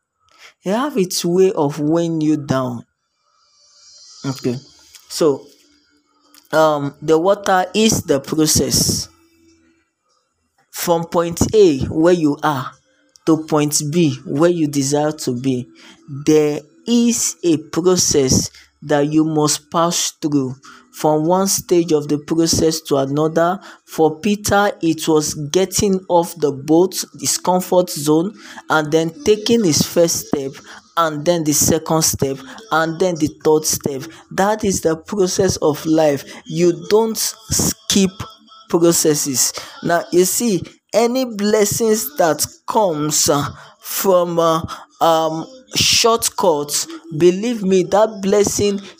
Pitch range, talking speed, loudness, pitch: 150-200 Hz, 120 wpm, -17 LUFS, 165 Hz